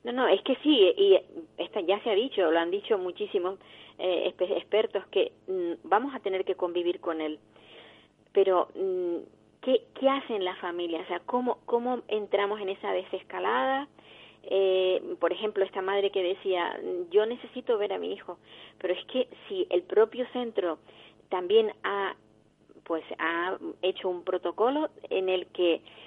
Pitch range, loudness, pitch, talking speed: 185-300 Hz, -28 LUFS, 205 Hz, 165 wpm